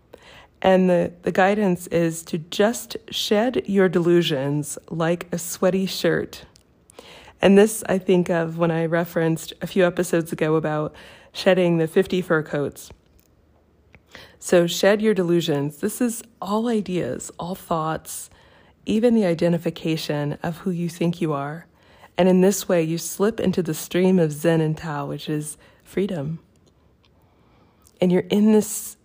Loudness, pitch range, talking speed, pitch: -22 LUFS, 155-190 Hz, 145 wpm, 170 Hz